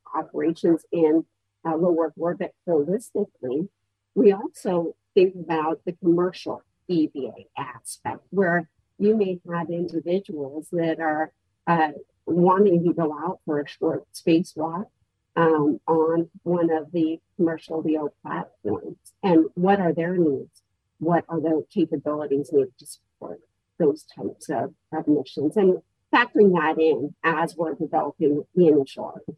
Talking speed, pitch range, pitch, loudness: 130 wpm, 155-175 Hz, 165 Hz, -24 LUFS